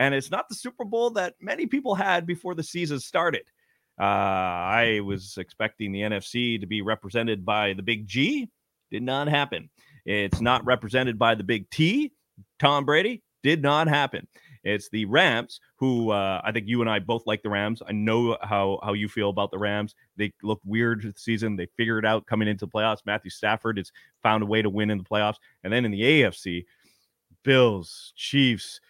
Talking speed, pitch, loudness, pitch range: 200 wpm, 110 Hz, -25 LUFS, 105-135 Hz